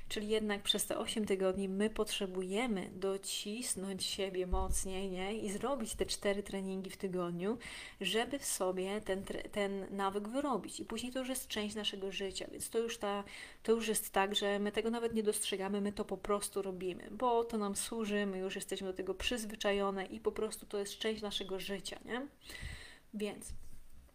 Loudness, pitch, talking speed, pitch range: -37 LUFS, 205 Hz, 180 wpm, 195-215 Hz